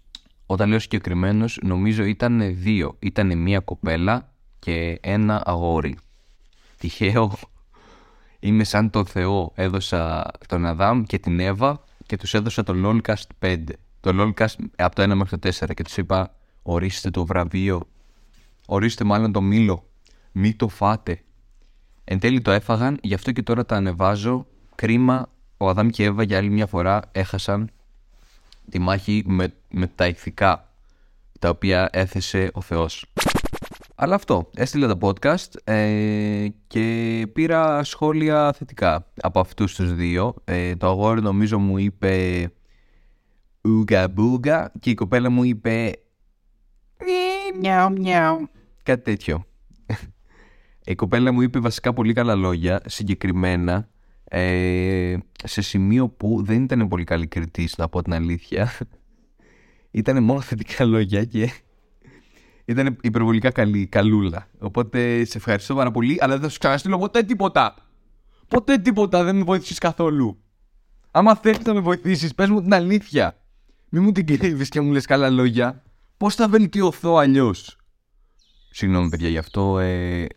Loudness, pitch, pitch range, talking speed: -21 LUFS, 105 Hz, 95-125 Hz, 140 wpm